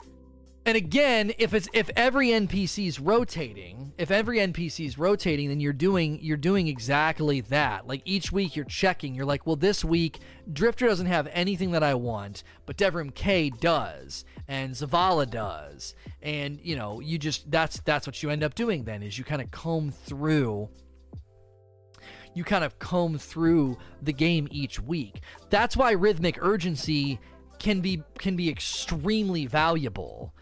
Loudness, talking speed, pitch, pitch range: -27 LUFS, 165 wpm, 155 Hz, 130-185 Hz